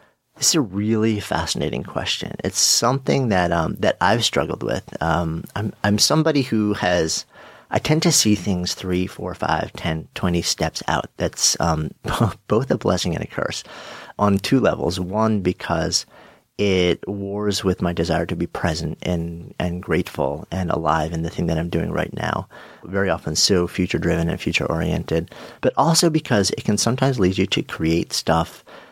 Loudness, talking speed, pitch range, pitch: -21 LUFS, 175 wpm, 85-105 Hz, 95 Hz